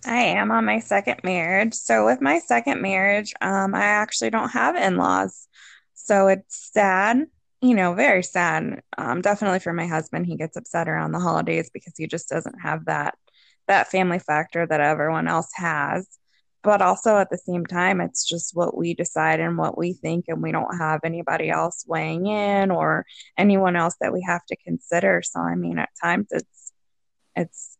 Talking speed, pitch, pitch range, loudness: 185 wpm, 180 Hz, 165-205 Hz, -22 LUFS